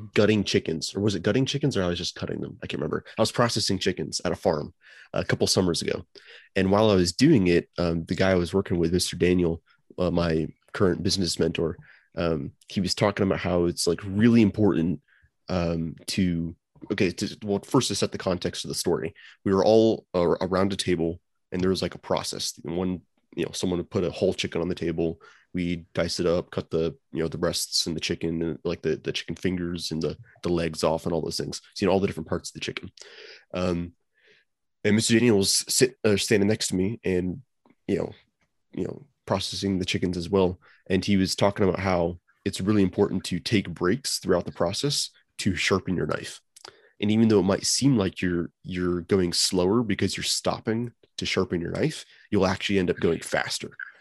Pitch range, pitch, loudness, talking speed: 85-100 Hz, 90 Hz, -25 LUFS, 215 wpm